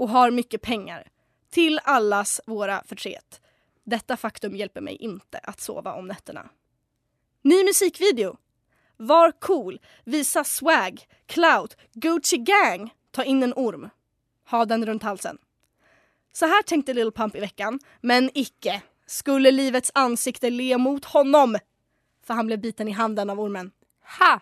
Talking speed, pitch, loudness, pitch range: 145 wpm, 250 Hz, -22 LUFS, 220-300 Hz